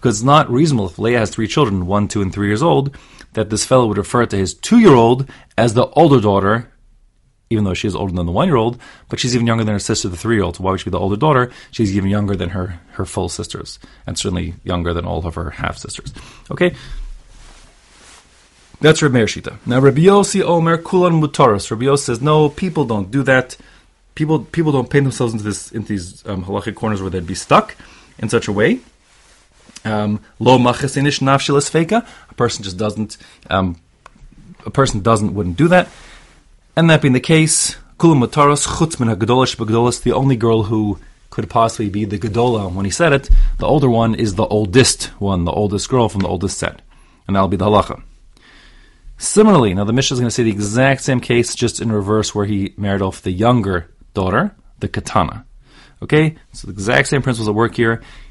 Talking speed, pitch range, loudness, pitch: 200 wpm, 100-135 Hz, -16 LUFS, 115 Hz